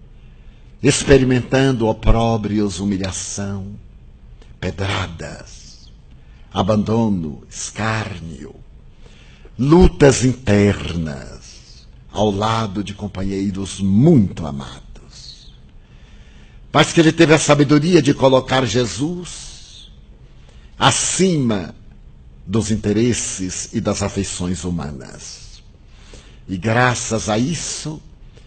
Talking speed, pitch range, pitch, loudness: 70 wpm, 95-125 Hz, 105 Hz, -17 LUFS